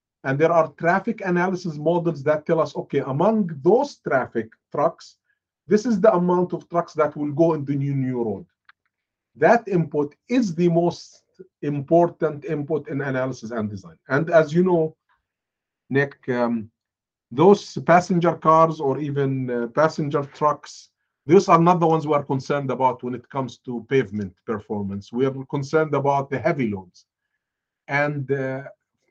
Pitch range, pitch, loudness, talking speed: 135-170 Hz, 150 Hz, -22 LUFS, 160 wpm